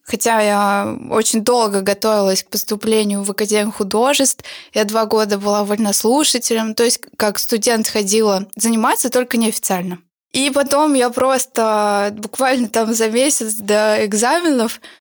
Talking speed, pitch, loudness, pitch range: 130 wpm, 225 Hz, -16 LUFS, 210-245 Hz